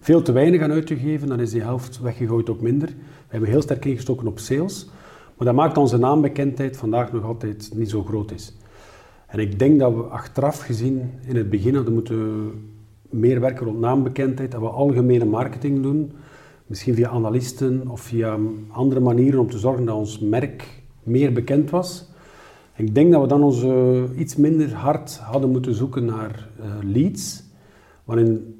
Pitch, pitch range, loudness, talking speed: 125 Hz, 115-140 Hz, -21 LUFS, 180 wpm